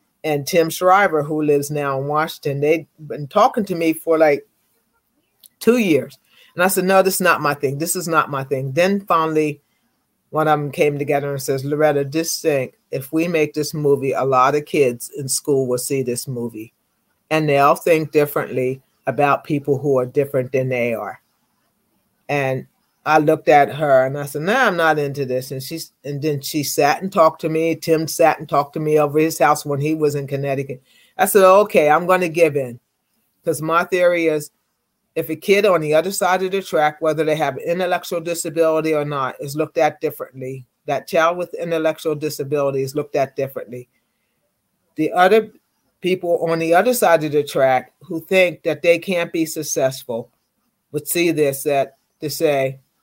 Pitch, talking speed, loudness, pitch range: 155 Hz, 200 wpm, -18 LUFS, 140-165 Hz